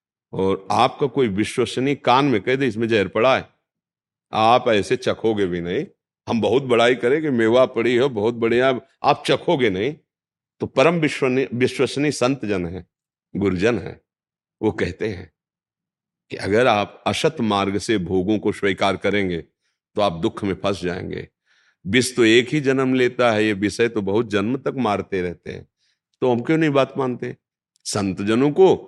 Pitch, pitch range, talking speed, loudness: 115 Hz, 100-130 Hz, 170 wpm, -20 LUFS